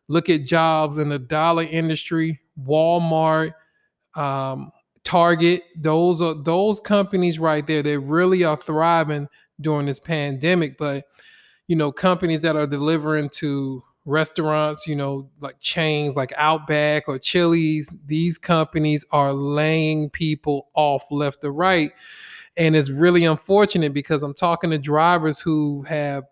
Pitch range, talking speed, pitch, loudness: 145-170 Hz, 135 wpm, 155 Hz, -20 LUFS